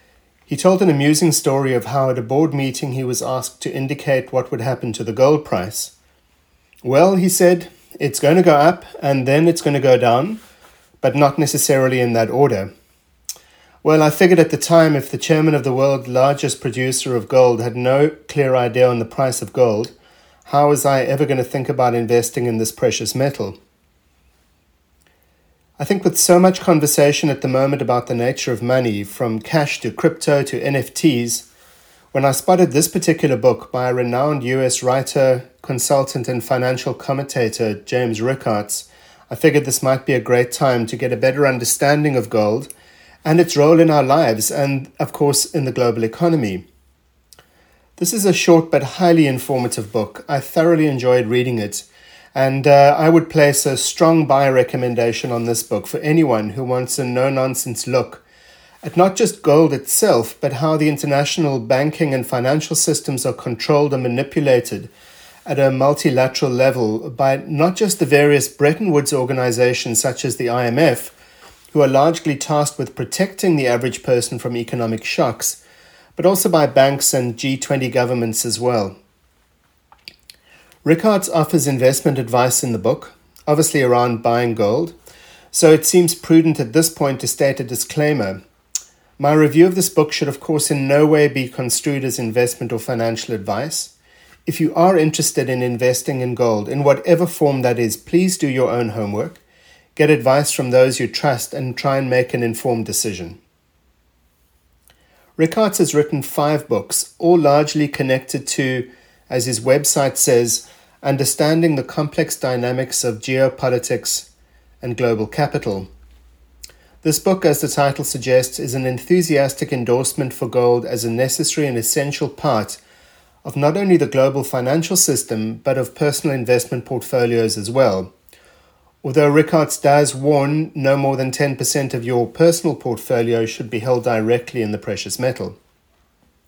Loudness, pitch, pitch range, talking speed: -17 LUFS, 135 Hz, 120-150 Hz, 165 wpm